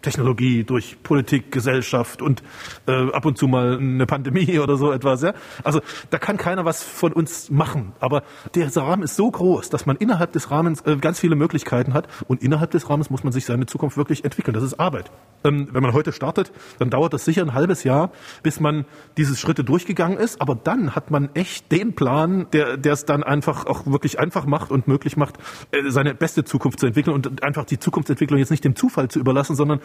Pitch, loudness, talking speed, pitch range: 145 Hz, -21 LUFS, 215 wpm, 135-160 Hz